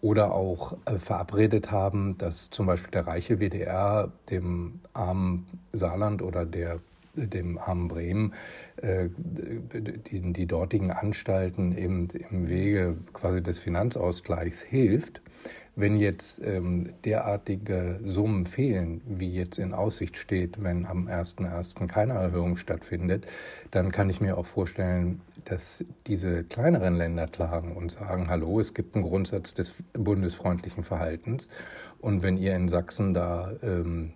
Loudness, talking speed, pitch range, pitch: -29 LUFS, 135 wpm, 85-100 Hz, 90 Hz